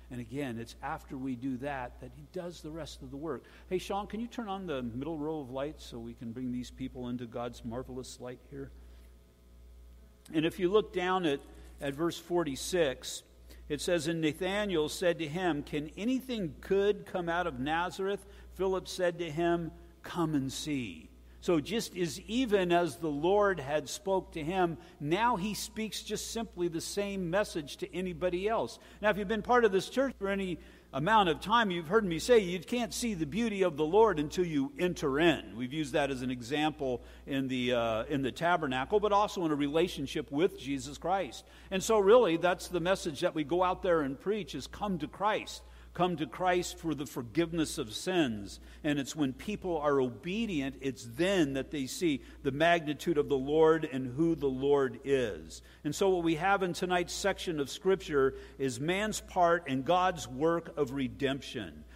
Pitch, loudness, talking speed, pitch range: 165 Hz, -32 LUFS, 195 wpm, 135-185 Hz